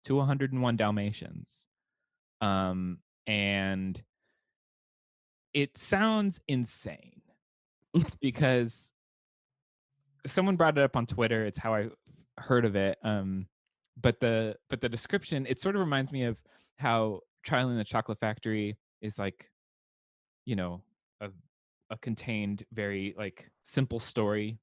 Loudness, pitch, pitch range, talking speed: -31 LUFS, 115 Hz, 105-135 Hz, 120 wpm